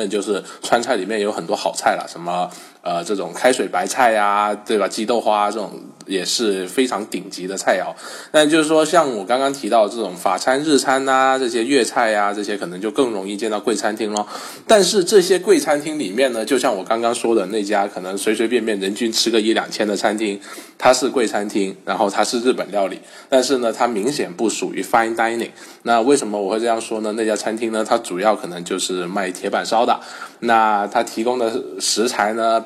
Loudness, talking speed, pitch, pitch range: -19 LUFS, 335 characters per minute, 115 Hz, 105-125 Hz